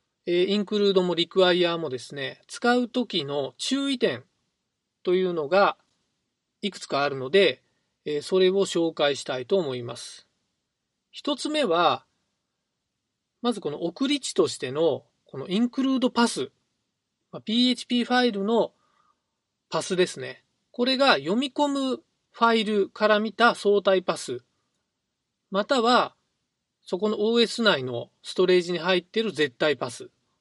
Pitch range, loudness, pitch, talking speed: 175-240 Hz, -24 LUFS, 200 Hz, 260 characters per minute